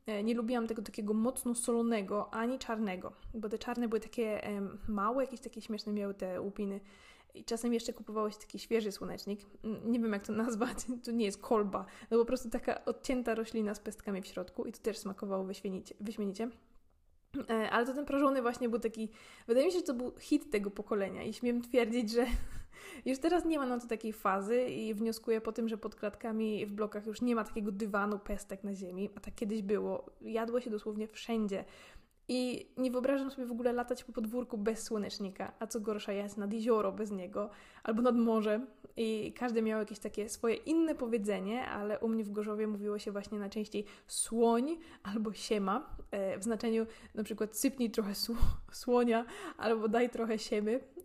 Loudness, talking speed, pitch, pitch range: -36 LUFS, 190 wpm, 225 Hz, 210-240 Hz